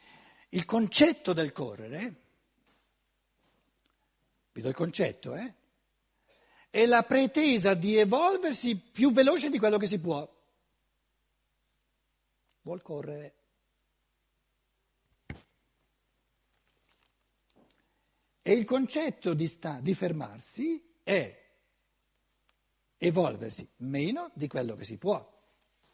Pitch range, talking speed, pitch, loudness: 155-250 Hz, 90 wpm, 190 Hz, -29 LUFS